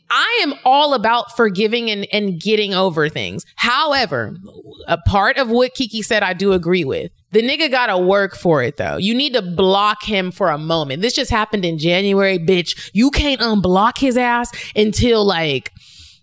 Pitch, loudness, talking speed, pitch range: 210 Hz, -16 LUFS, 180 wpm, 185-240 Hz